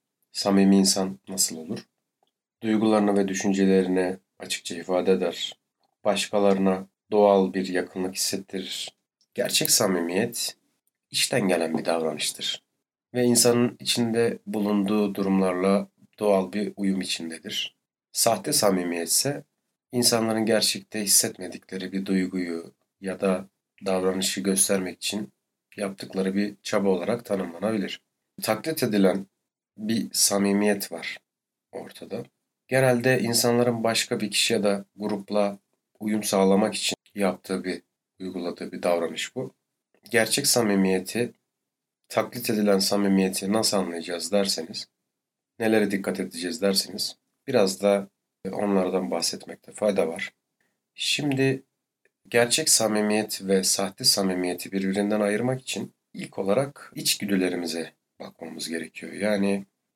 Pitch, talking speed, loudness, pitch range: 100 Hz, 105 wpm, -24 LUFS, 95-110 Hz